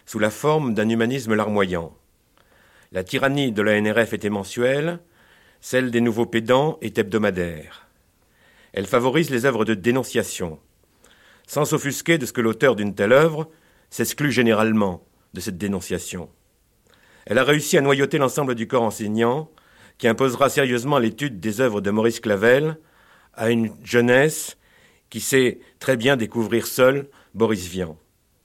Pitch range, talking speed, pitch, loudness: 105-135 Hz, 145 wpm, 115 Hz, -21 LUFS